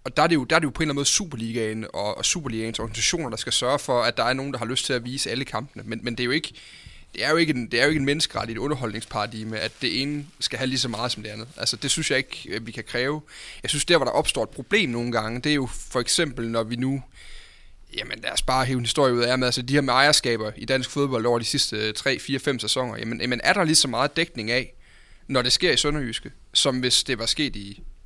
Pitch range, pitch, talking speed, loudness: 115-145 Hz, 125 Hz, 280 wpm, -23 LUFS